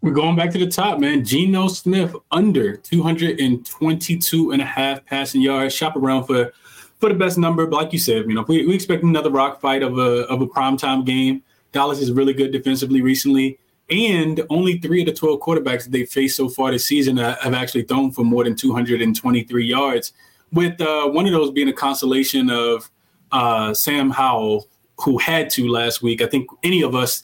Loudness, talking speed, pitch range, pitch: -18 LUFS, 200 wpm, 125-160 Hz, 135 Hz